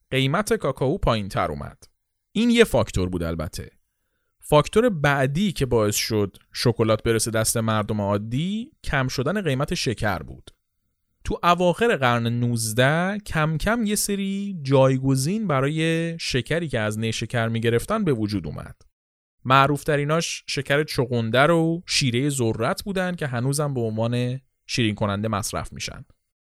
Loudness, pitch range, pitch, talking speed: -23 LUFS, 110-160 Hz, 130 Hz, 135 wpm